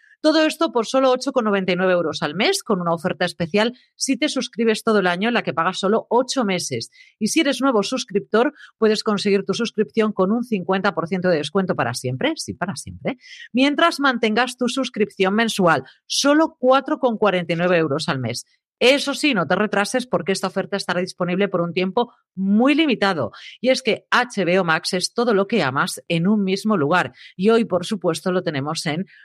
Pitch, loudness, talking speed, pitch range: 205 Hz, -20 LUFS, 185 wpm, 180-250 Hz